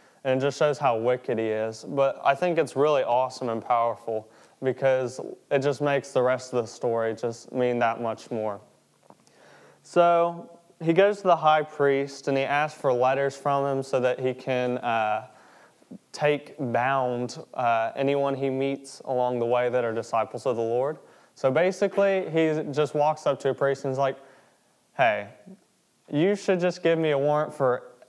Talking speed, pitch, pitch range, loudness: 180 wpm, 135 Hz, 125-150 Hz, -25 LUFS